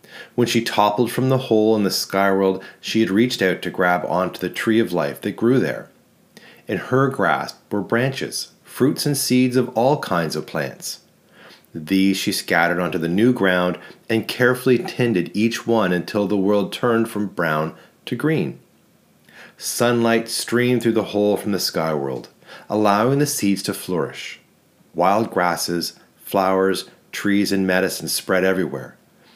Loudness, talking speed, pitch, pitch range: -20 LUFS, 160 wpm, 105 Hz, 95-120 Hz